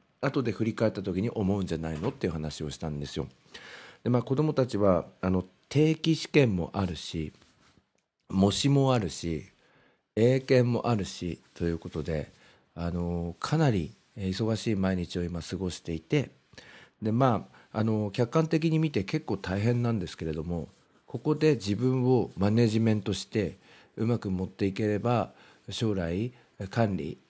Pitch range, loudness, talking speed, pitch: 85-120 Hz, -29 LUFS, 270 characters per minute, 100 Hz